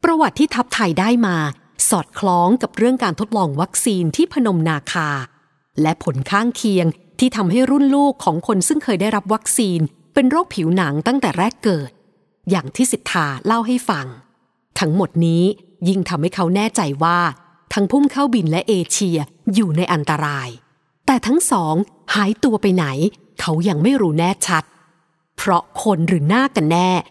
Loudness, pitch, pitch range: -18 LUFS, 190 Hz, 165-230 Hz